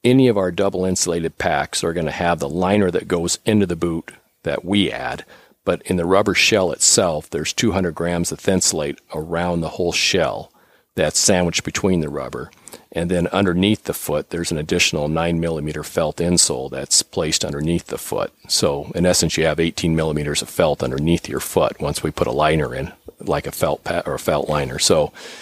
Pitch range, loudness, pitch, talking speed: 80-90 Hz, -19 LUFS, 85 Hz, 200 wpm